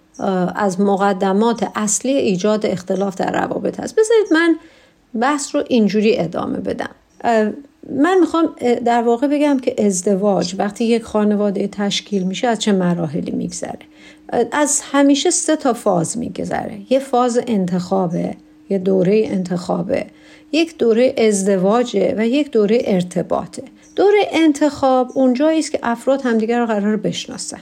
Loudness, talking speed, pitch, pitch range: -17 LUFS, 130 wpm, 235 Hz, 200-280 Hz